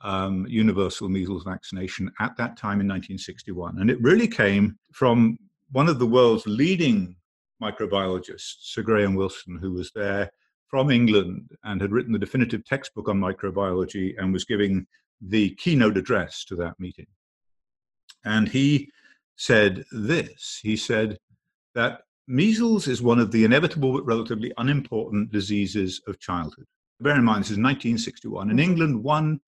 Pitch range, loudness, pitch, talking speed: 95-120 Hz, -24 LUFS, 105 Hz, 150 wpm